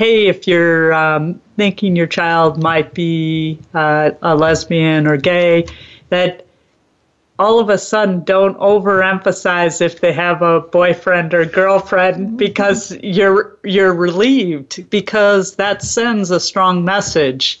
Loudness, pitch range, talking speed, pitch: -14 LUFS, 165-200 Hz, 130 wpm, 180 Hz